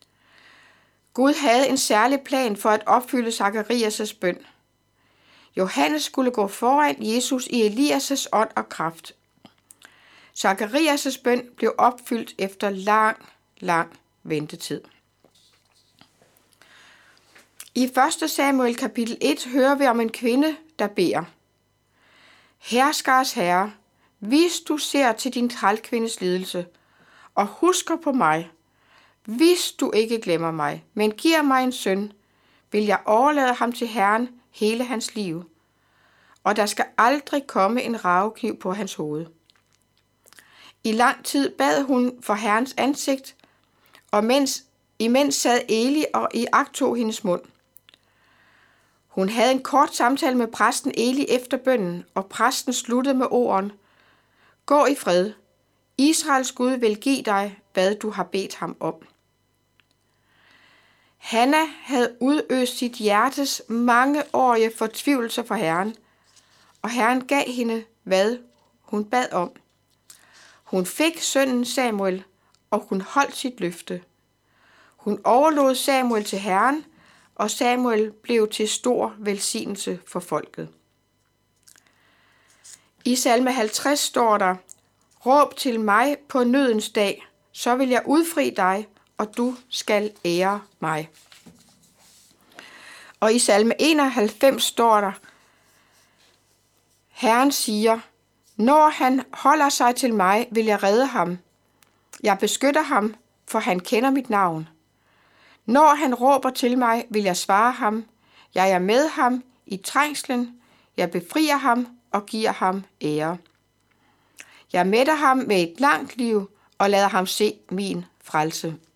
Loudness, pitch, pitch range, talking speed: -22 LUFS, 230 Hz, 195-265 Hz, 125 wpm